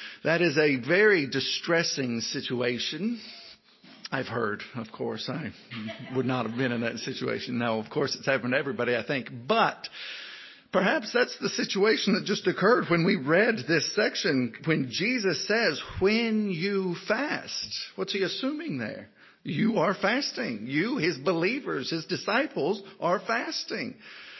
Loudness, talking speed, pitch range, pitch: -27 LUFS, 150 wpm, 130-215 Hz, 175 Hz